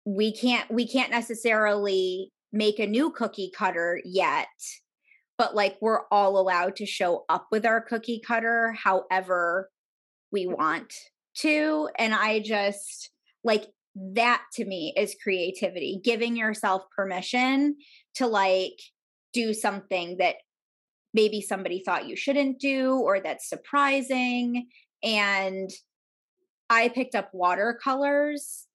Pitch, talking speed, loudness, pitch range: 220 Hz, 120 wpm, -26 LUFS, 195-245 Hz